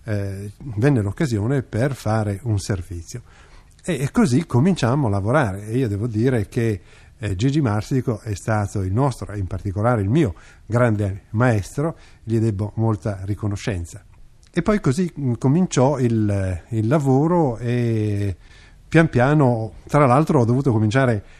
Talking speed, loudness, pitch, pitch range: 130 wpm, -21 LUFS, 115 Hz, 100-135 Hz